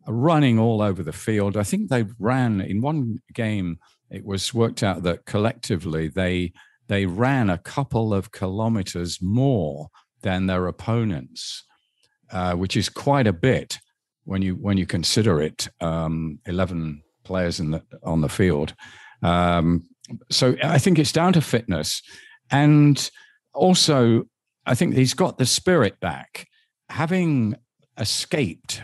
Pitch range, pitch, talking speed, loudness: 90-130 Hz, 105 Hz, 140 wpm, -22 LUFS